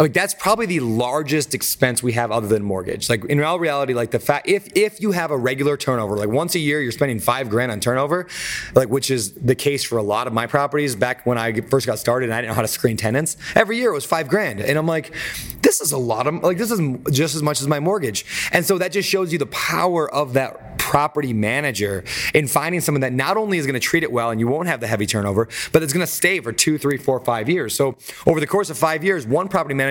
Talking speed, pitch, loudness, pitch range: 270 wpm, 145 Hz, -20 LUFS, 120-165 Hz